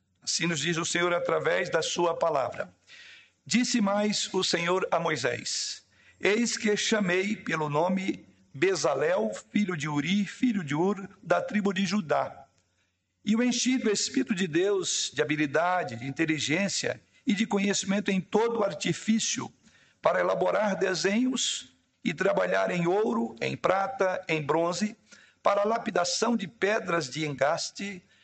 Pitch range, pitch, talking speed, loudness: 165-220 Hz, 195 Hz, 140 wpm, -27 LUFS